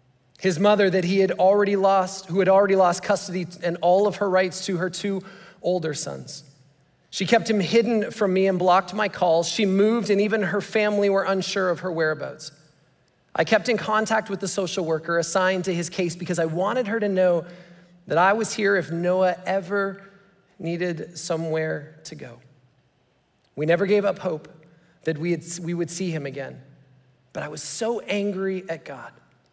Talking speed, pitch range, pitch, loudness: 185 wpm, 165-200 Hz, 185 Hz, -23 LUFS